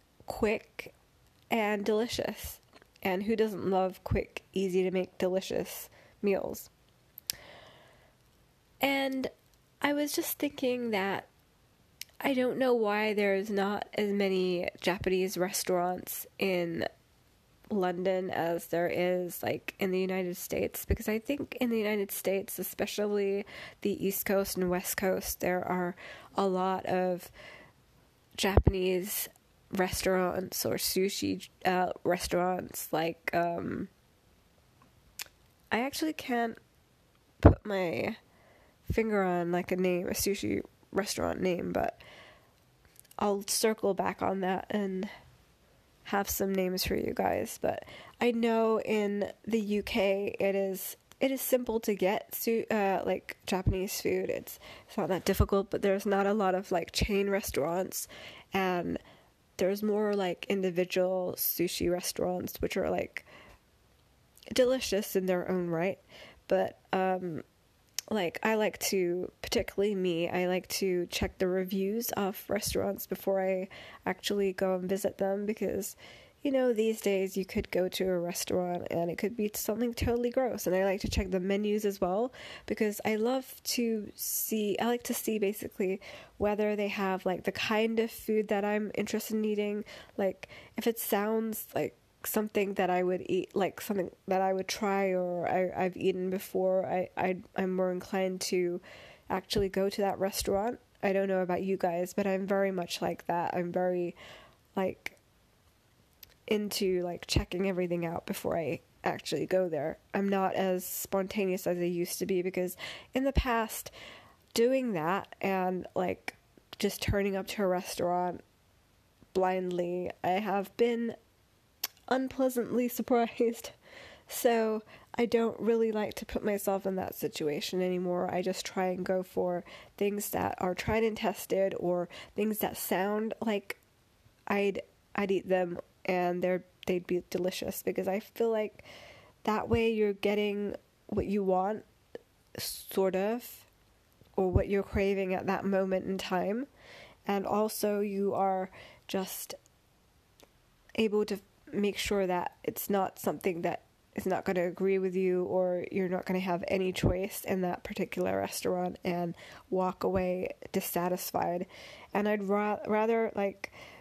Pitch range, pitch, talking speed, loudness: 185-210 Hz, 195 Hz, 145 wpm, -32 LUFS